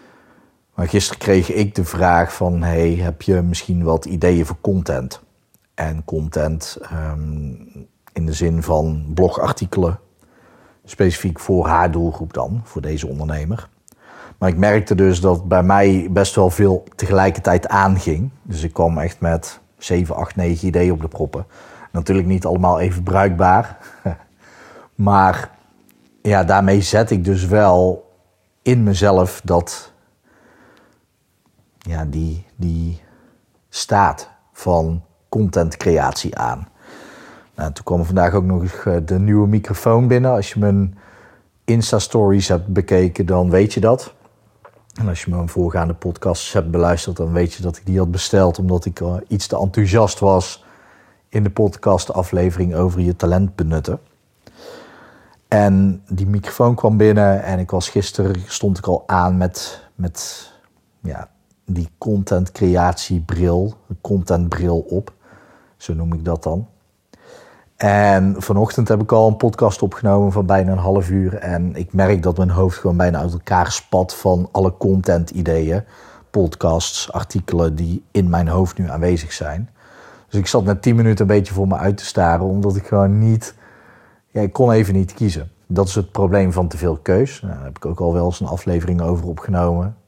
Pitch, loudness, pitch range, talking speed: 95 Hz, -17 LUFS, 85-100 Hz, 155 wpm